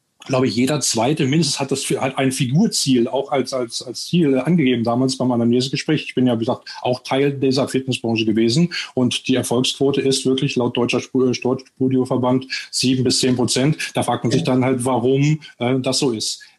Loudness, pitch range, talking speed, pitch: -19 LUFS, 125-140 Hz, 190 wpm, 130 Hz